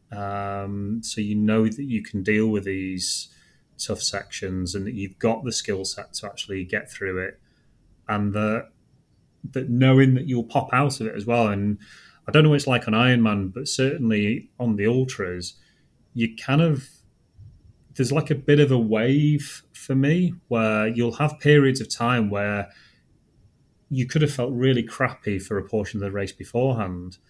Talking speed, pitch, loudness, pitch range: 180 wpm, 115 Hz, -23 LUFS, 100-130 Hz